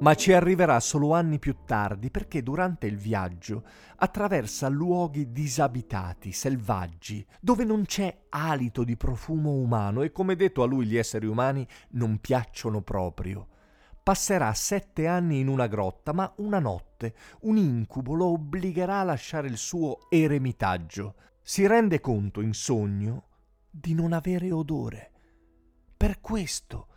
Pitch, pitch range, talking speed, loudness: 135 Hz, 105-170 Hz, 140 wpm, -27 LUFS